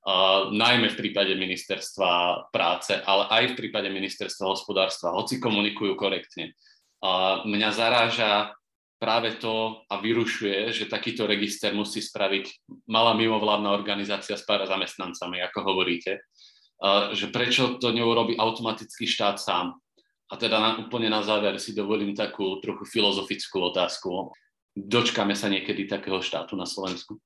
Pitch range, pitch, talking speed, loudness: 100-115 Hz, 105 Hz, 135 wpm, -25 LUFS